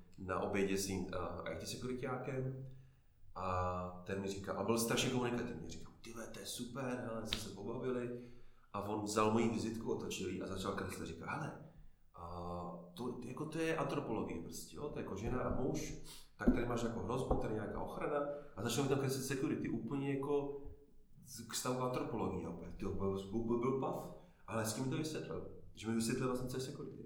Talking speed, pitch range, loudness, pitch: 195 wpm, 95-125 Hz, -41 LUFS, 115 Hz